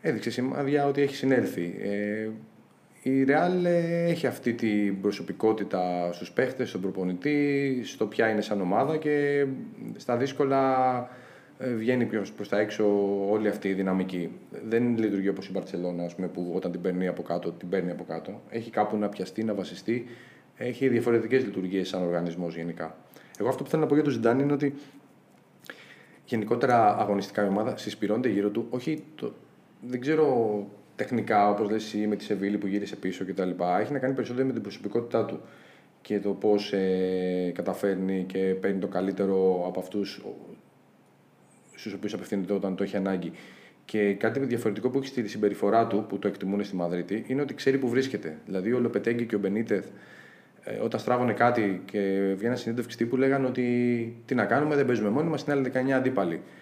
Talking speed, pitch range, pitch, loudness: 175 wpm, 95-125 Hz, 105 Hz, -28 LUFS